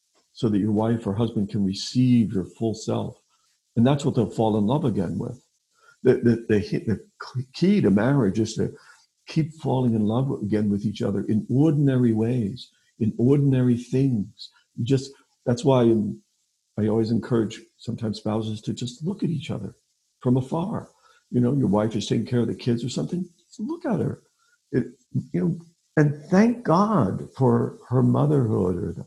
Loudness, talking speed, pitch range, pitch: -24 LUFS, 180 wpm, 110-140 Hz, 120 Hz